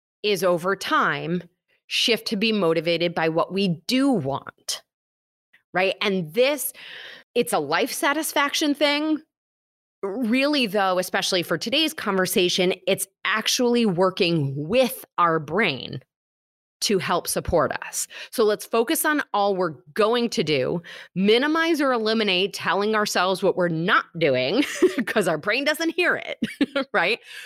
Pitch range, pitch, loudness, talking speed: 180-260 Hz, 210 Hz, -22 LUFS, 135 wpm